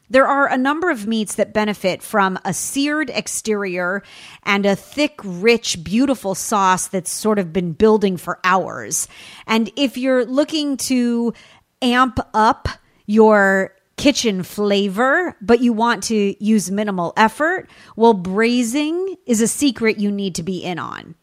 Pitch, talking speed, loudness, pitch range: 220 Hz, 150 wpm, -18 LUFS, 195-255 Hz